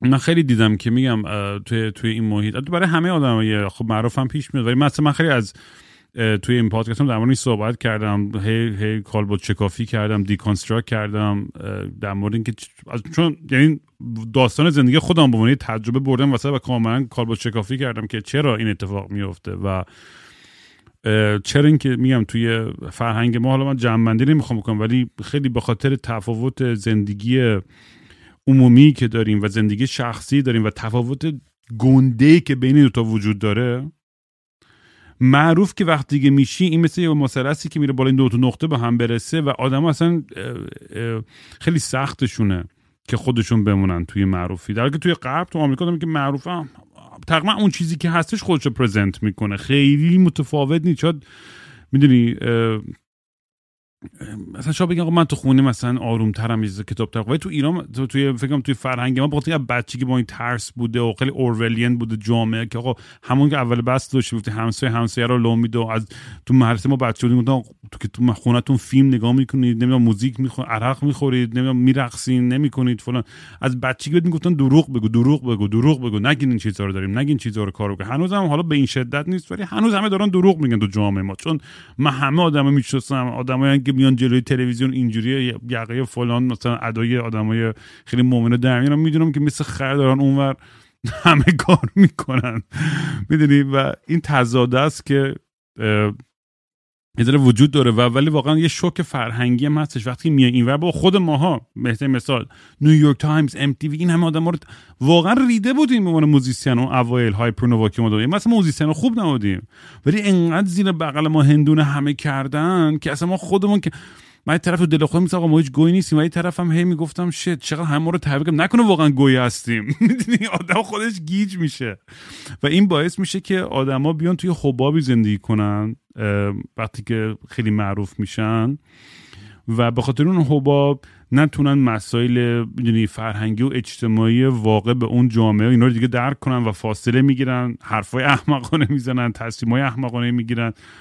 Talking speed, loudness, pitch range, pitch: 175 wpm, -18 LUFS, 115-150 Hz, 130 Hz